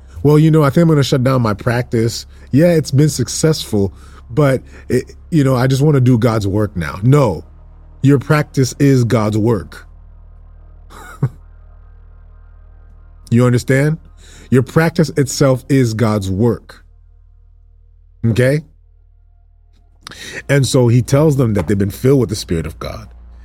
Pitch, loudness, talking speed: 105 Hz, -14 LUFS, 145 wpm